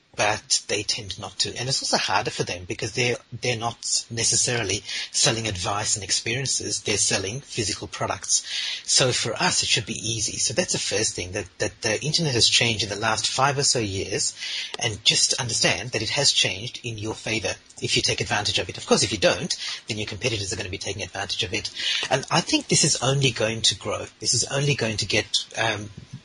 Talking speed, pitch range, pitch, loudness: 220 wpm, 105-130 Hz, 115 Hz, -23 LUFS